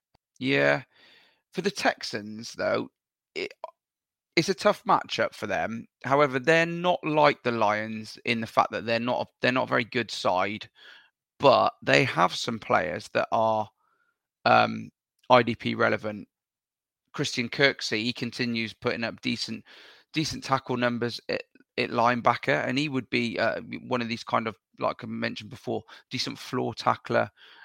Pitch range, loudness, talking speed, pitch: 115-150 Hz, -26 LUFS, 155 wpm, 120 Hz